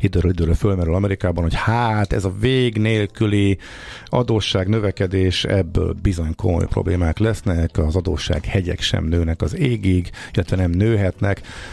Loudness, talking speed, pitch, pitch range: -20 LUFS, 140 wpm, 95 Hz, 90-110 Hz